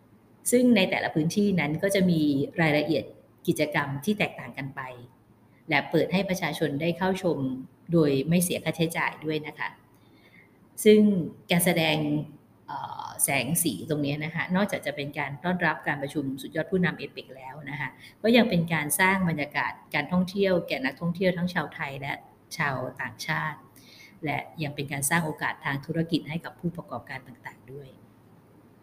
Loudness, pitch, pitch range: -26 LUFS, 155 Hz, 140-175 Hz